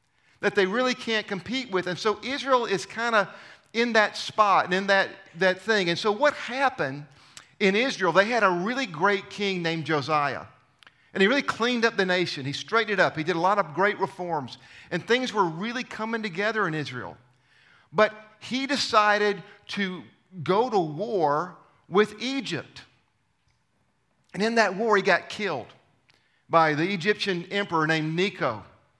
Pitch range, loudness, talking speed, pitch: 170-220 Hz, -25 LUFS, 170 wpm, 200 Hz